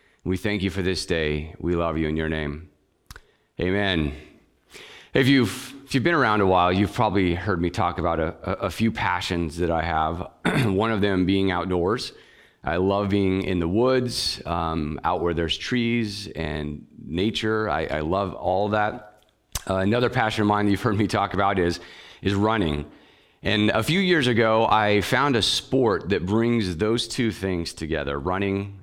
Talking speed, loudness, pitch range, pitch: 180 wpm, -23 LUFS, 85-110 Hz, 100 Hz